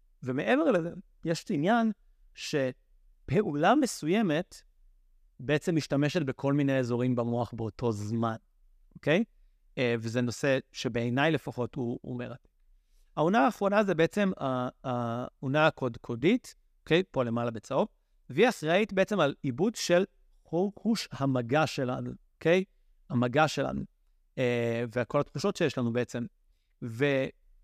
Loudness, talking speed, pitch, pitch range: -29 LUFS, 110 wpm, 135 Hz, 120-170 Hz